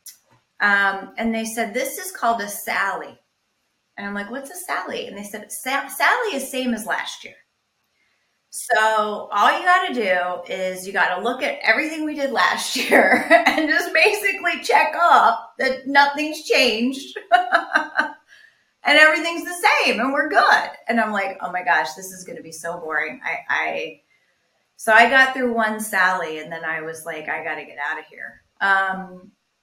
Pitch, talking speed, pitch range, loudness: 235 Hz, 175 wpm, 195-310 Hz, -19 LUFS